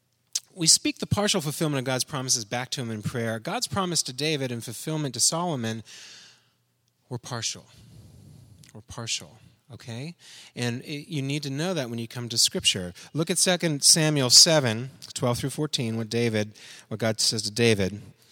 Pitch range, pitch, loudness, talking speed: 115-155 Hz, 130 Hz, -24 LUFS, 175 wpm